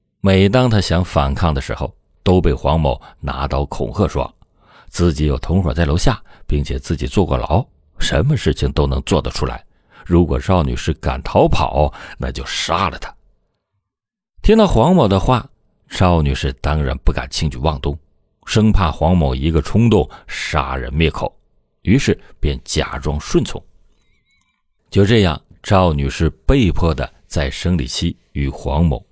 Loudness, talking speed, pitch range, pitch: -17 LUFS, 225 characters per minute, 70-90 Hz, 80 Hz